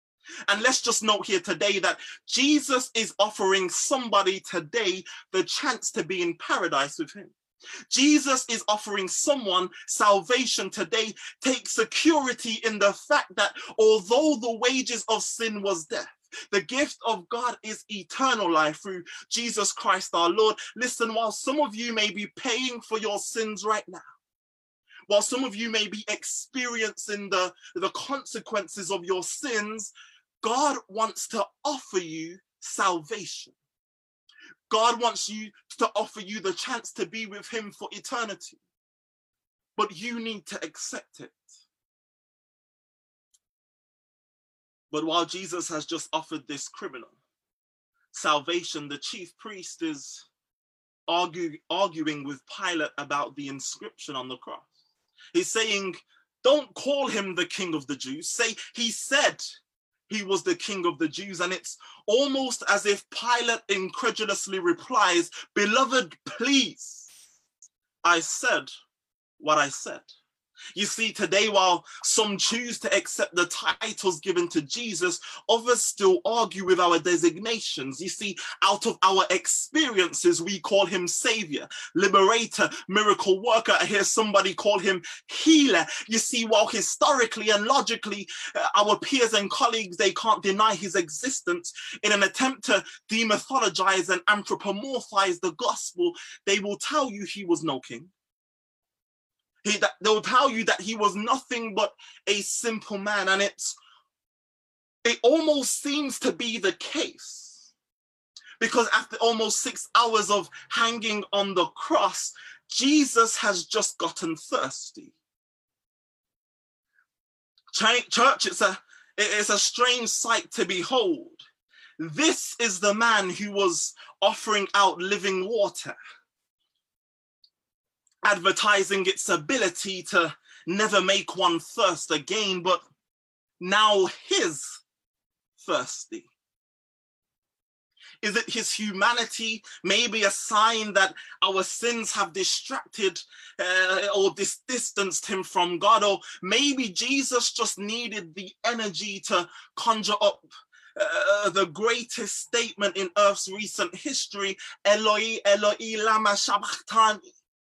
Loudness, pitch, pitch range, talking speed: -25 LUFS, 215 Hz, 195-250 Hz, 130 wpm